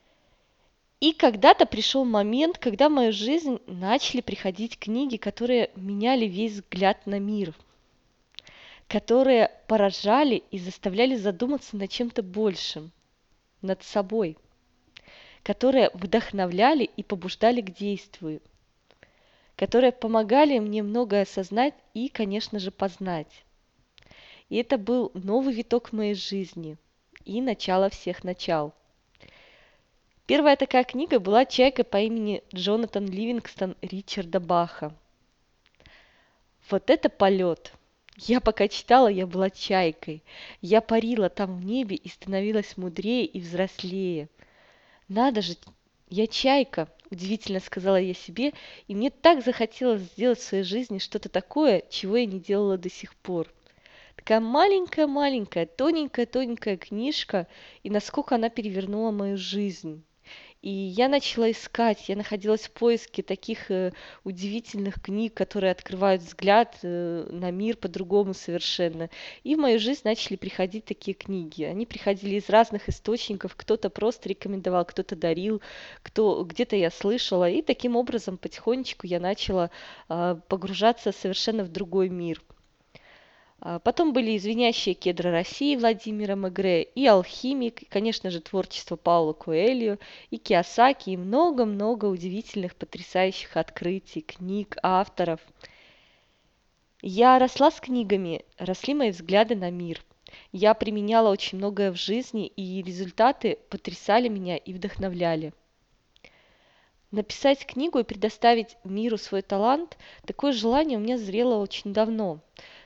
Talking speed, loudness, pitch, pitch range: 120 wpm, -25 LUFS, 205 Hz, 190-235 Hz